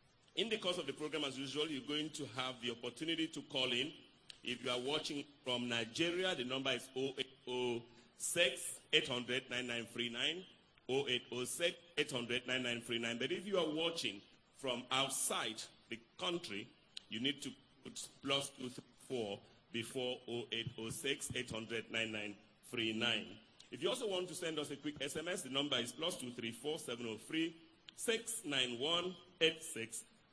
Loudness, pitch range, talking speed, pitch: -40 LUFS, 120-155 Hz, 120 wpm, 130 Hz